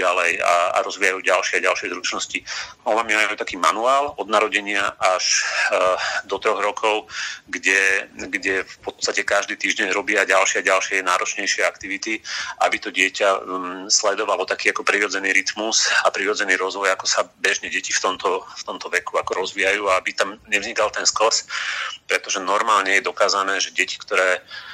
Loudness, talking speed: -20 LUFS, 160 wpm